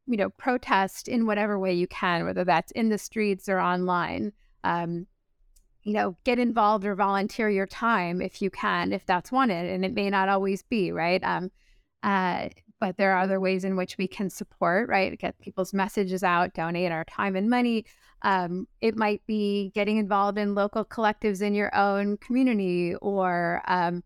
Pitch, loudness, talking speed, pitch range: 195 Hz, -26 LUFS, 185 wpm, 185-210 Hz